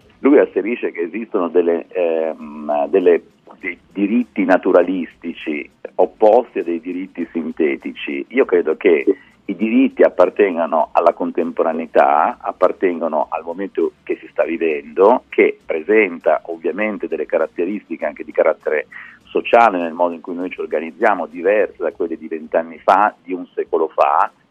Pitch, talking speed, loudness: 390 Hz, 135 wpm, -18 LUFS